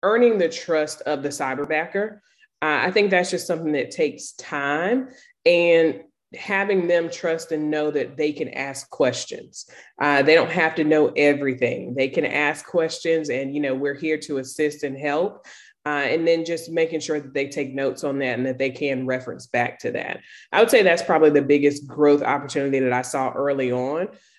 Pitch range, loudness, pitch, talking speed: 140-165 Hz, -22 LUFS, 150 Hz, 195 wpm